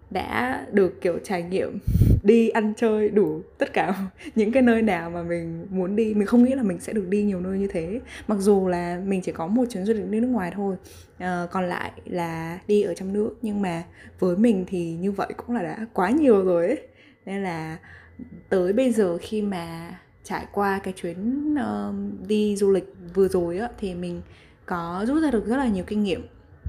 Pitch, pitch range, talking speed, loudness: 195 Hz, 180-220 Hz, 210 wpm, -24 LUFS